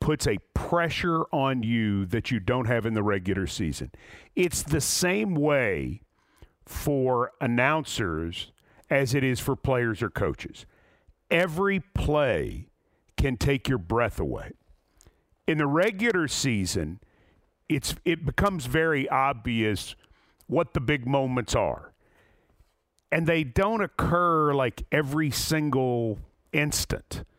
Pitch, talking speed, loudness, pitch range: 135 Hz, 120 wpm, -26 LUFS, 115-155 Hz